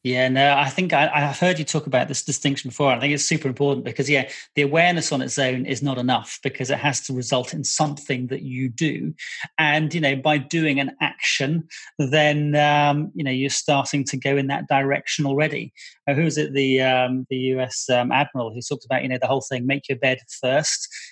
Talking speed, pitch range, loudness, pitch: 220 wpm, 130-150 Hz, -21 LUFS, 140 Hz